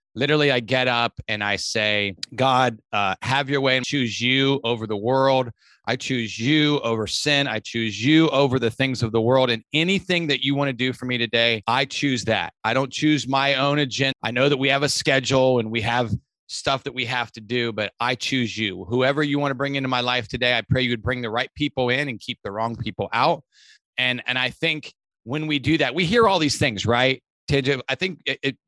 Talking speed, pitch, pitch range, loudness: 235 wpm, 130 Hz, 115-140 Hz, -21 LUFS